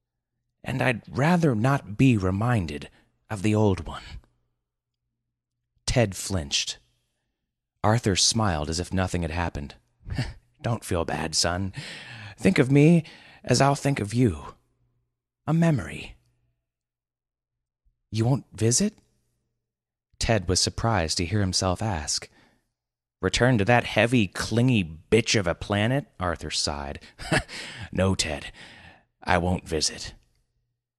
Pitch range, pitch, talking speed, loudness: 85-120 Hz, 105 Hz, 115 wpm, -24 LUFS